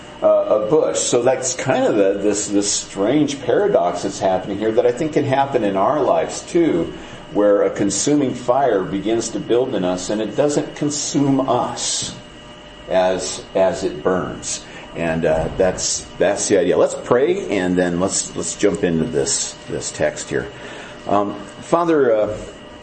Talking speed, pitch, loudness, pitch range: 165 wpm, 100 Hz, -18 LUFS, 90-135 Hz